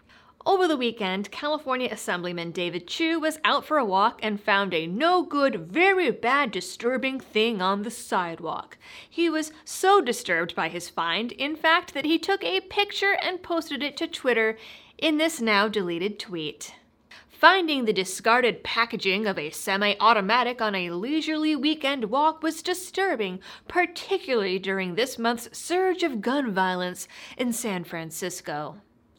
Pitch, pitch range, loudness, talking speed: 240 Hz, 195-320 Hz, -25 LUFS, 150 wpm